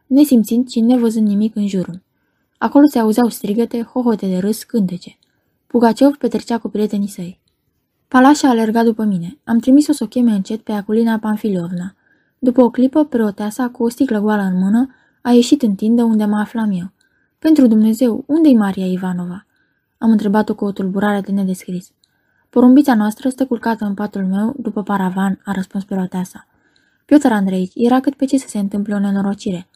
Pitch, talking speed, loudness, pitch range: 220 Hz, 175 wpm, -16 LUFS, 200-245 Hz